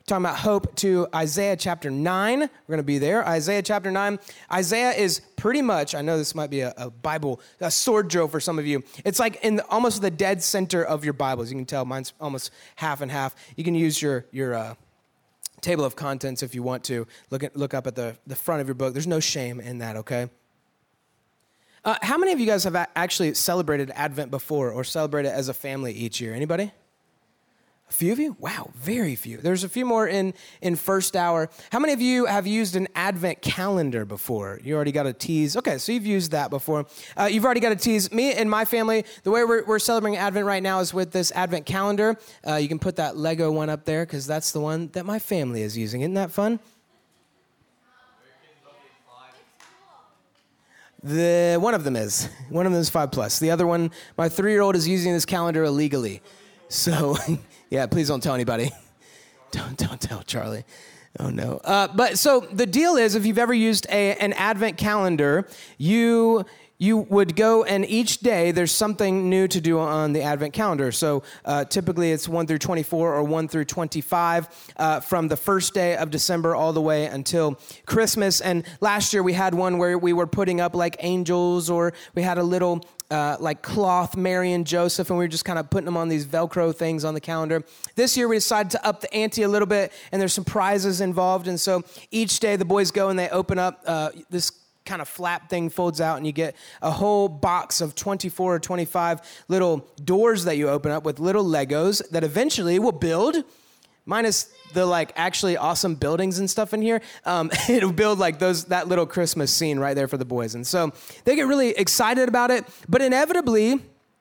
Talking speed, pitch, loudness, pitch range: 210 wpm, 175 Hz, -23 LUFS, 150-200 Hz